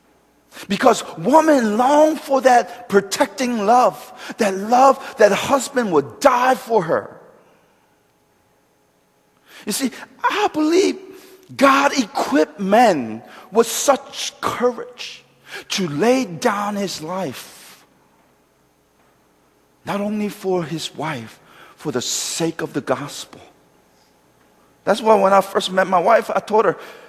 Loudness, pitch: -18 LUFS, 210 Hz